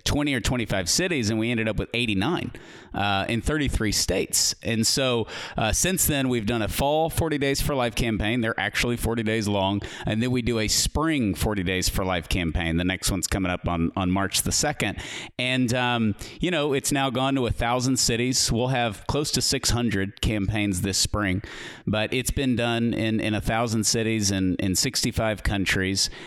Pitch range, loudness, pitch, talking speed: 100-125 Hz, -24 LUFS, 115 Hz, 195 wpm